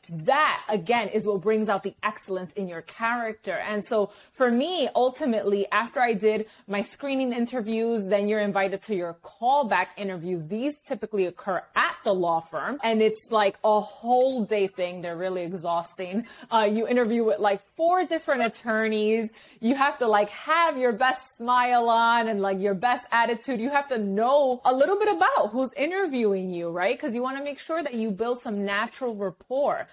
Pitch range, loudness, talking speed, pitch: 200-255 Hz, -25 LUFS, 185 wpm, 220 Hz